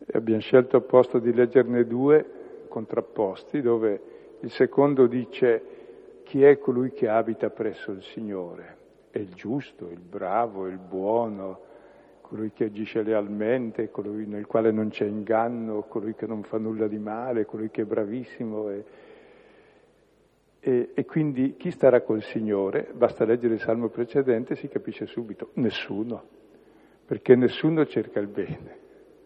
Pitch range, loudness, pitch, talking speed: 110-140 Hz, -25 LUFS, 115 Hz, 145 wpm